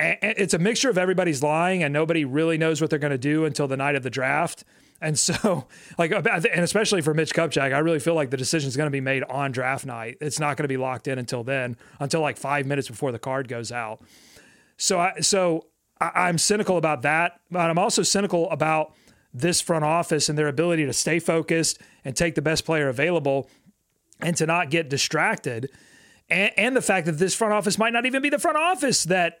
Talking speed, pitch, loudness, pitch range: 225 wpm, 160 Hz, -23 LUFS, 140-180 Hz